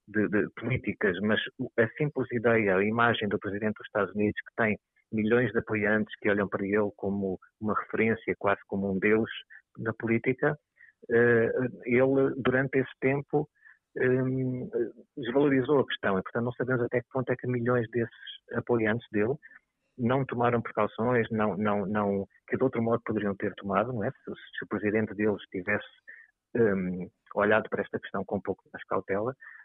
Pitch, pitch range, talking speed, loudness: 115 Hz, 105-125 Hz, 170 wpm, -29 LUFS